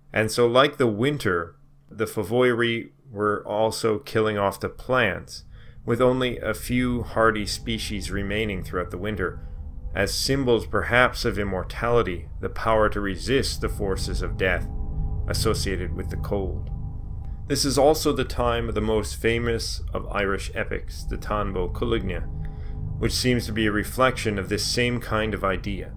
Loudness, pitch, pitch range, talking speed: -25 LUFS, 105 Hz, 95-120 Hz, 155 wpm